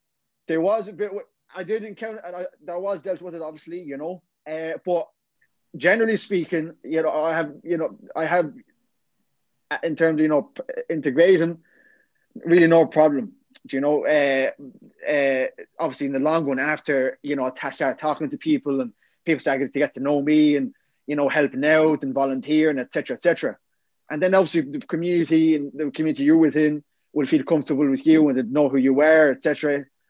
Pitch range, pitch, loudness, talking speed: 145-180 Hz, 160 Hz, -22 LUFS, 185 wpm